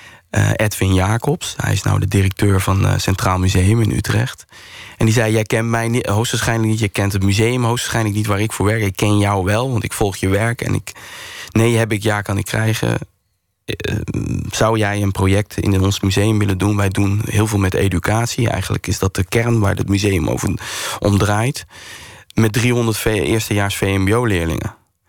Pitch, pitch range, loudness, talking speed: 105 Hz, 100-115 Hz, -17 LUFS, 195 wpm